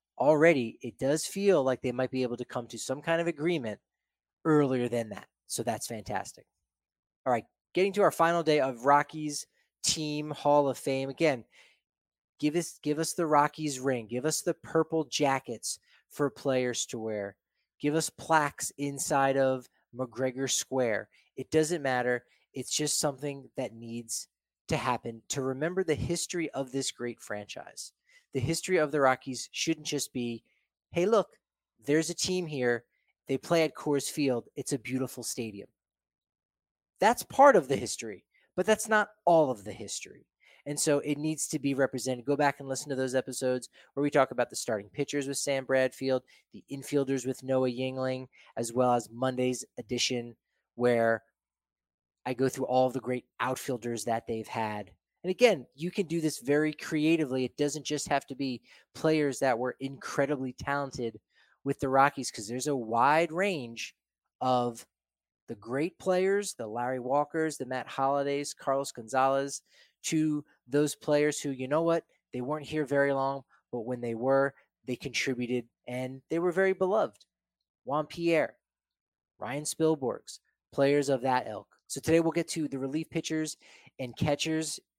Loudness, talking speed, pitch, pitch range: -30 LUFS, 165 wpm, 135 Hz, 125-150 Hz